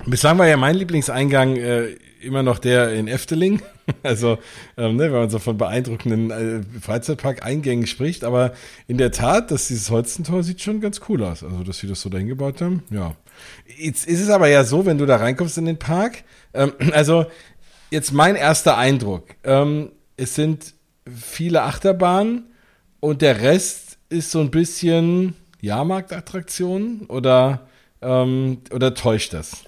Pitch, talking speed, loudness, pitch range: 140 Hz, 160 wpm, -19 LUFS, 120-170 Hz